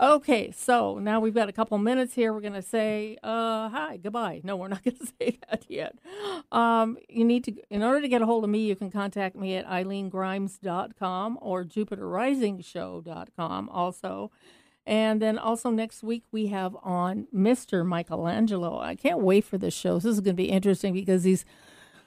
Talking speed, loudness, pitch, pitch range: 190 wpm, -27 LUFS, 215 Hz, 190-230 Hz